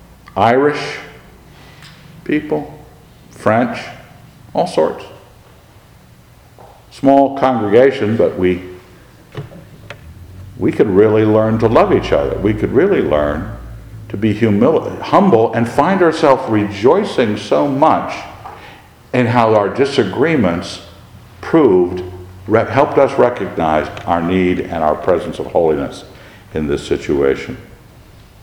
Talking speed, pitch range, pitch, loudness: 105 wpm, 90-125 Hz, 110 Hz, -14 LUFS